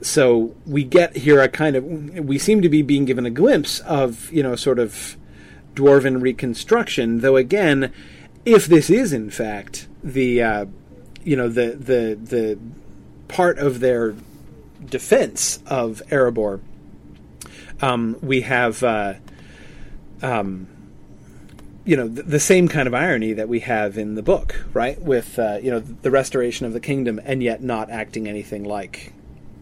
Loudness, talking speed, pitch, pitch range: -19 LUFS, 155 wpm, 125 Hz, 110-140 Hz